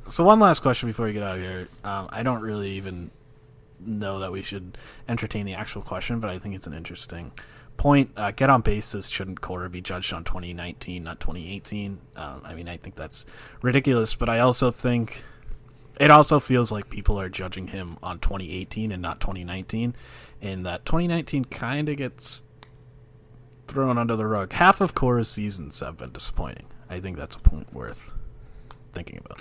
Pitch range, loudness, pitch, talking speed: 95-125 Hz, -25 LUFS, 105 Hz, 185 wpm